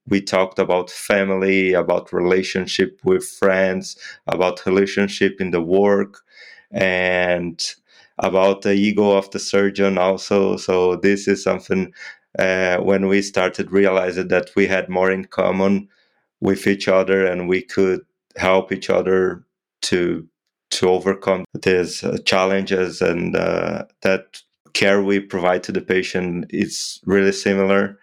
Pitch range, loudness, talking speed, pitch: 95-100 Hz, -19 LUFS, 135 wpm, 95 Hz